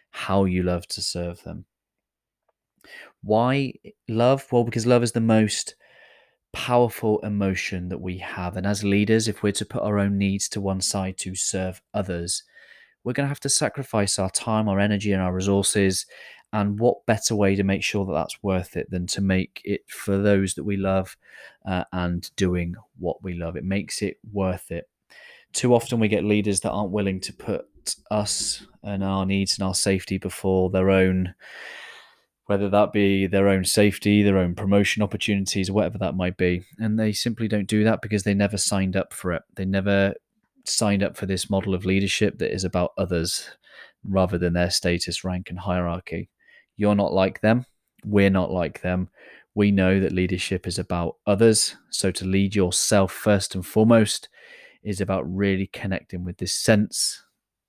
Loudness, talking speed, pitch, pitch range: -23 LUFS, 180 wpm, 100 Hz, 95-105 Hz